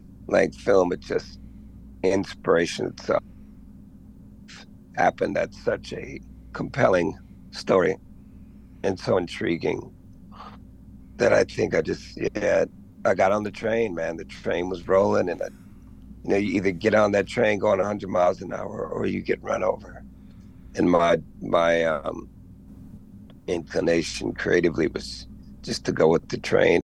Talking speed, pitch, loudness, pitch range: 145 wpm, 95 Hz, -24 LUFS, 85-105 Hz